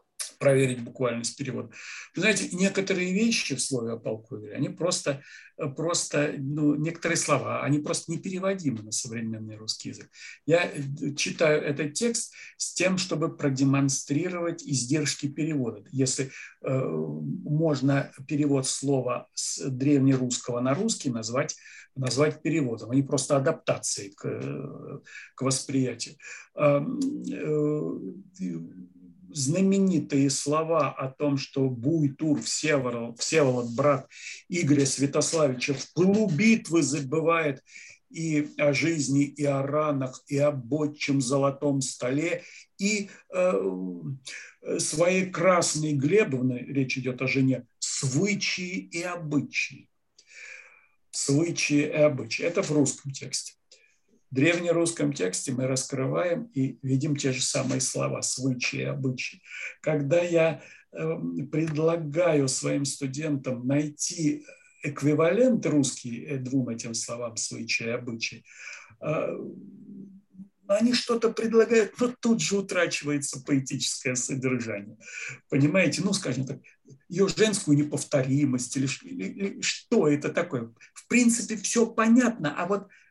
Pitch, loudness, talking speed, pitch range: 145 Hz, -27 LUFS, 110 wpm, 130-170 Hz